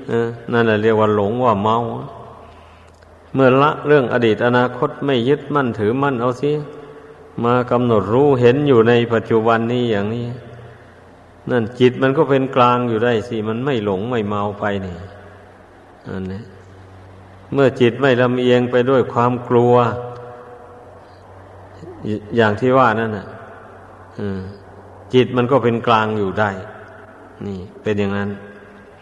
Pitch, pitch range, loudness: 115 Hz, 100-125 Hz, -17 LUFS